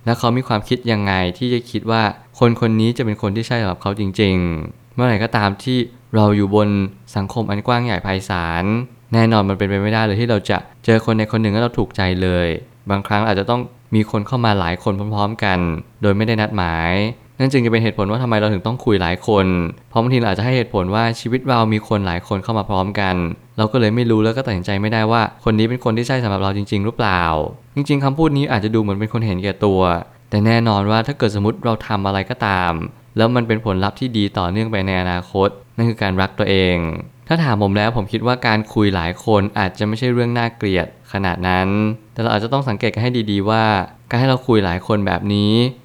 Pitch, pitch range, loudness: 110 Hz, 100-115 Hz, -18 LUFS